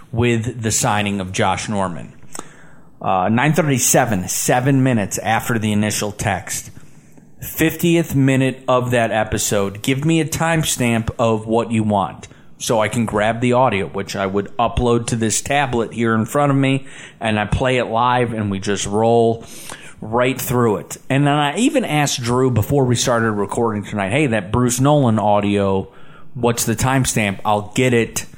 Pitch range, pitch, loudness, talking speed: 105-135 Hz, 120 Hz, -18 LUFS, 165 wpm